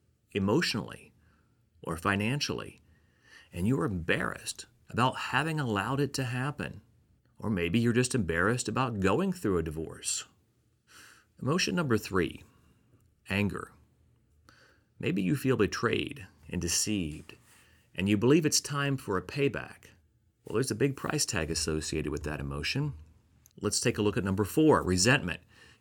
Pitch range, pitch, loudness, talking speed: 85-135 Hz, 105 Hz, -30 LUFS, 135 wpm